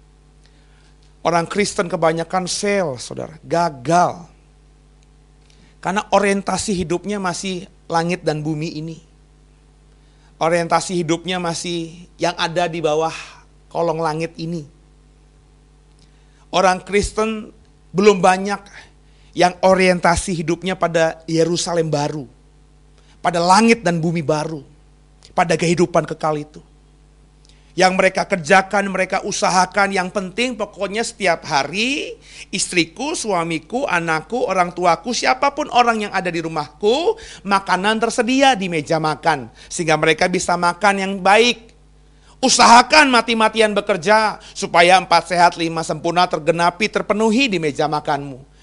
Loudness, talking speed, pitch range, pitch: -17 LUFS, 110 wpm, 150-195 Hz, 170 Hz